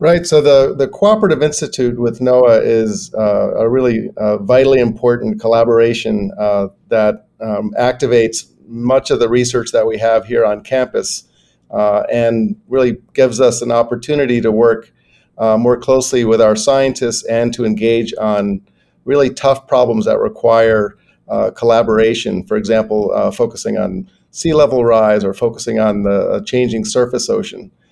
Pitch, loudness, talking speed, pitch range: 115 Hz, -14 LUFS, 155 wpm, 110-125 Hz